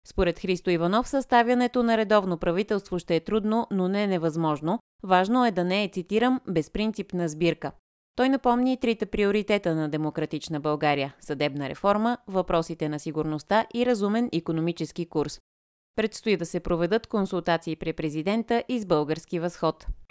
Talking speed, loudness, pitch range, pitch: 145 wpm, -26 LUFS, 165-220 Hz, 185 Hz